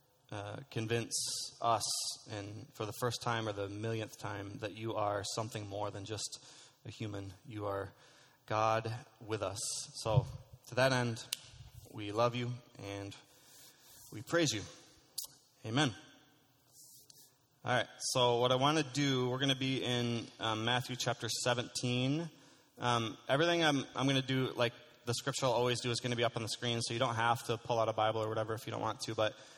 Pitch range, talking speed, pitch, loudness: 110-130 Hz, 190 wpm, 120 Hz, -35 LUFS